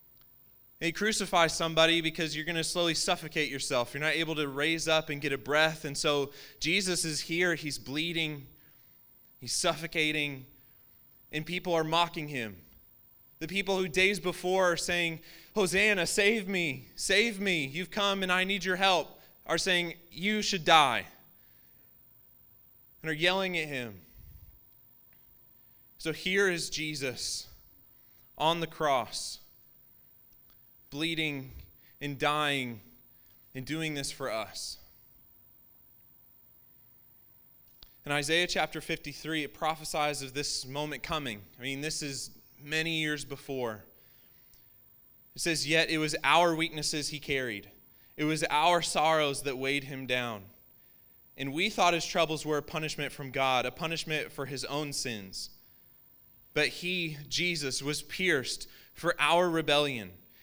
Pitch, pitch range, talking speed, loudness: 155 Hz, 135-170 Hz, 135 wpm, -30 LUFS